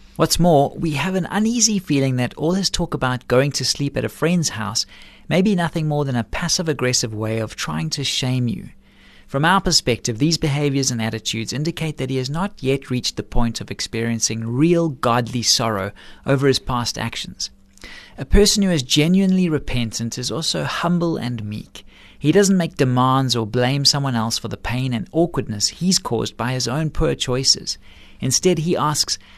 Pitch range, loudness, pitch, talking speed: 115-160 Hz, -19 LUFS, 130 Hz, 190 wpm